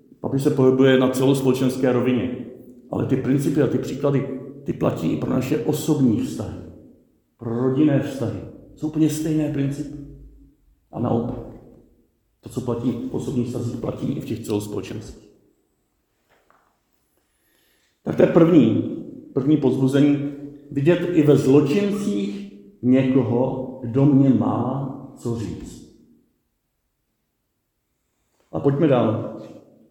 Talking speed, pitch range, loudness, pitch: 115 wpm, 120-145 Hz, -21 LUFS, 130 Hz